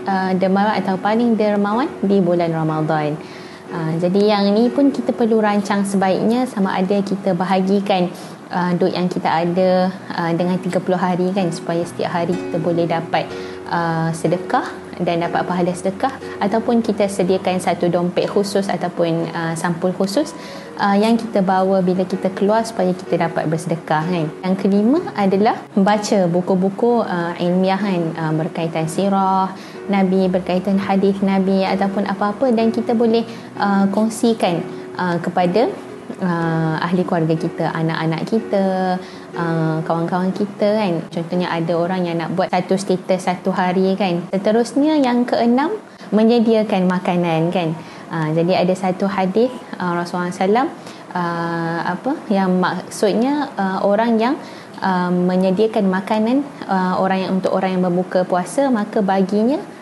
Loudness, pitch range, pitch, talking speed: -18 LUFS, 175-205 Hz, 190 Hz, 145 wpm